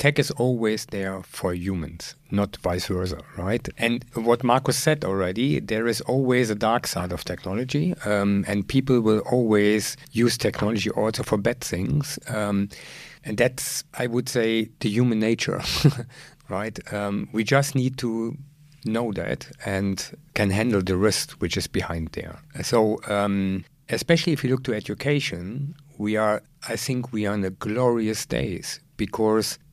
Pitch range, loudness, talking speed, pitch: 100-130 Hz, -24 LUFS, 160 wpm, 115 Hz